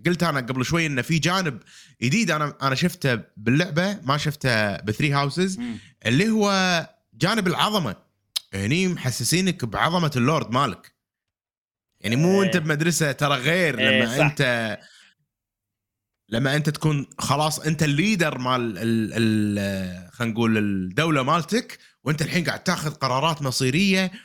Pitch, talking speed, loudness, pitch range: 145 Hz, 130 wpm, -22 LUFS, 120-170 Hz